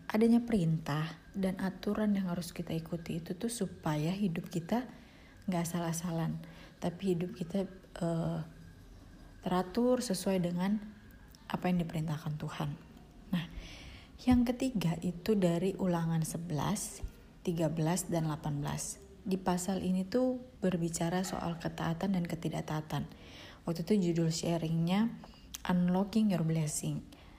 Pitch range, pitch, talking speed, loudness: 165-195 Hz, 180 Hz, 115 wpm, -34 LUFS